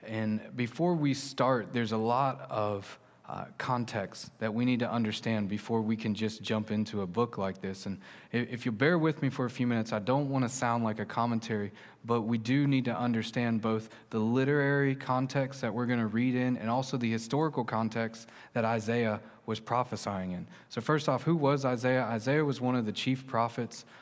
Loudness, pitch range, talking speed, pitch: -31 LUFS, 110-130 Hz, 205 wpm, 120 Hz